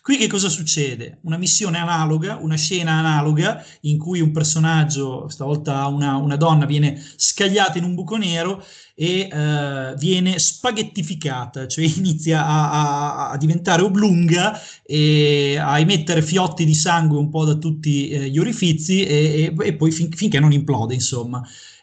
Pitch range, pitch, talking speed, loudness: 145-180 Hz, 160 Hz, 155 wpm, -18 LUFS